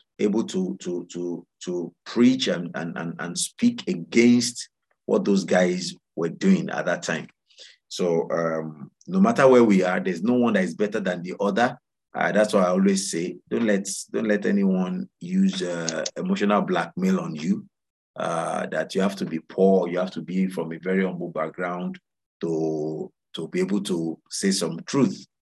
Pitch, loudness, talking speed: 95 Hz, -24 LUFS, 180 wpm